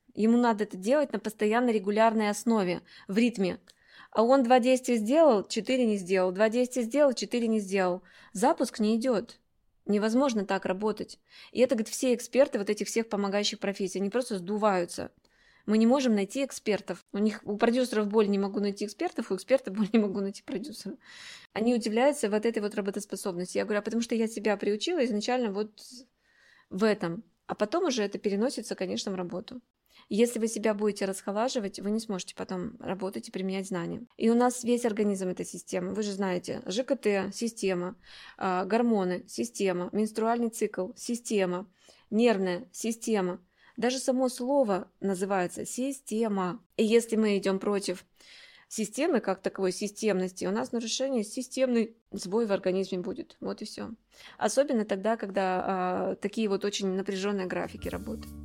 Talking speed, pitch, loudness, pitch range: 160 wpm, 215 Hz, -29 LUFS, 195-235 Hz